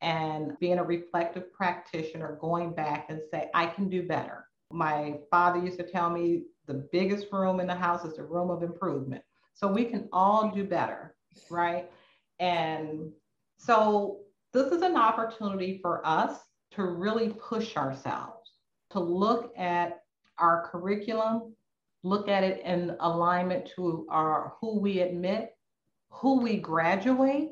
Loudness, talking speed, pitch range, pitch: -29 LUFS, 145 wpm, 170-200 Hz, 180 Hz